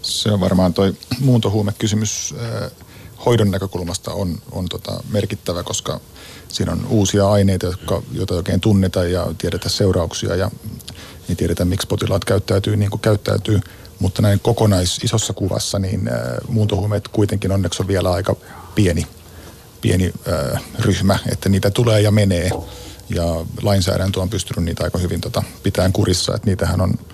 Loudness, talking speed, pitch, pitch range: -19 LUFS, 145 wpm, 100 Hz, 90-110 Hz